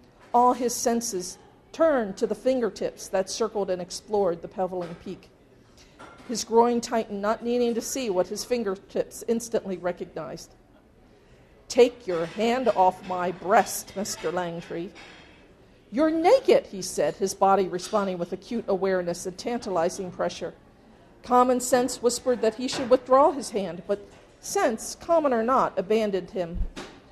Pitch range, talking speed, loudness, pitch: 185-245 Hz, 140 wpm, -25 LUFS, 215 Hz